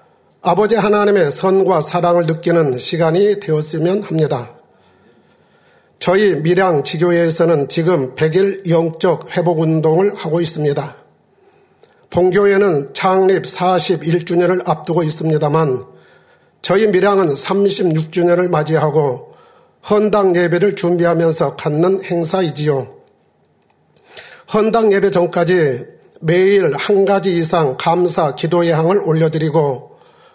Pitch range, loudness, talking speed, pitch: 160-190 Hz, -15 LUFS, 245 characters per minute, 175 Hz